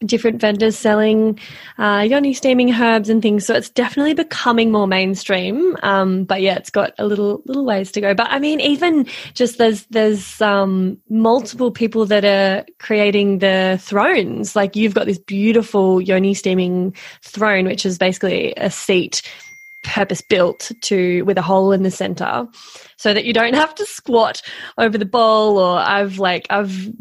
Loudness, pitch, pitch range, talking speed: -16 LUFS, 210 Hz, 195-230 Hz, 170 wpm